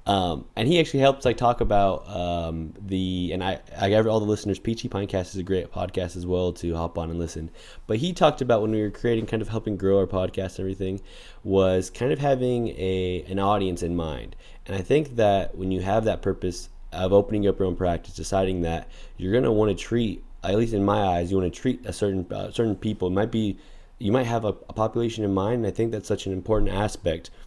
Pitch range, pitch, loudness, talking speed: 90-110 Hz, 100 Hz, -25 LUFS, 240 wpm